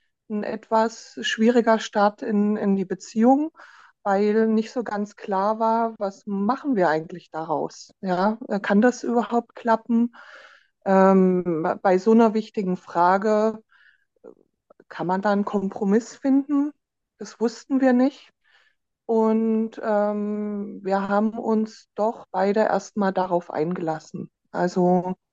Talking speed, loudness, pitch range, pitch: 120 wpm, -23 LUFS, 195-230 Hz, 210 Hz